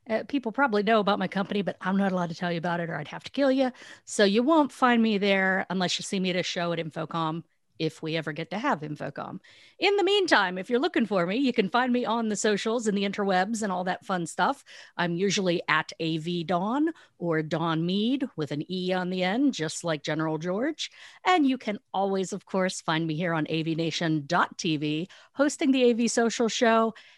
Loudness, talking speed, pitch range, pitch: -27 LUFS, 225 wpm, 170-235 Hz, 190 Hz